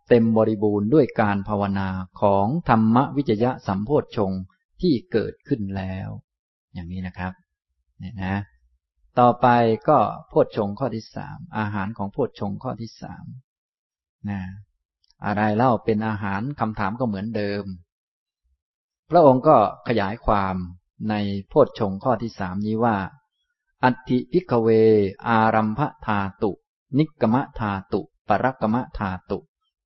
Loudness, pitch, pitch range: -22 LUFS, 105 Hz, 95-120 Hz